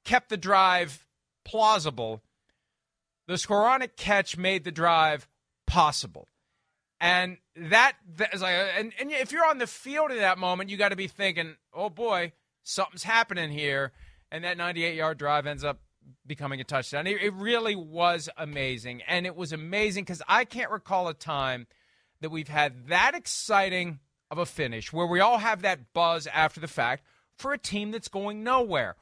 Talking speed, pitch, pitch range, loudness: 170 wpm, 180 Hz, 150-205 Hz, -27 LUFS